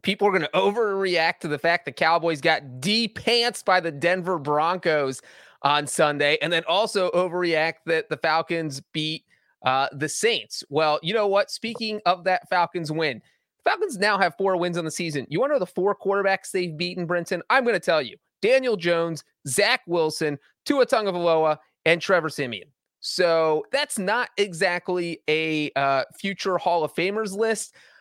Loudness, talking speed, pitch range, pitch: -23 LUFS, 175 wpm, 155-195 Hz, 175 Hz